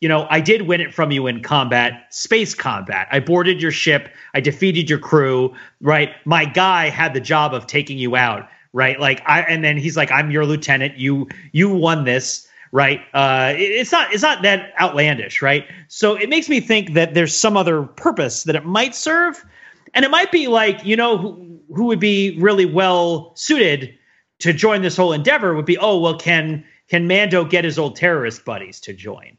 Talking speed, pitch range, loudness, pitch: 205 wpm, 145-195 Hz, -16 LUFS, 165 Hz